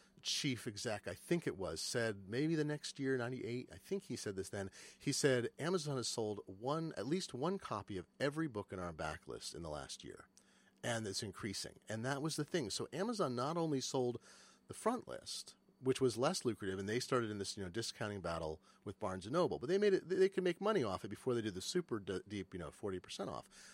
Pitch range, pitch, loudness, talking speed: 100-150 Hz, 120 Hz, -40 LUFS, 240 wpm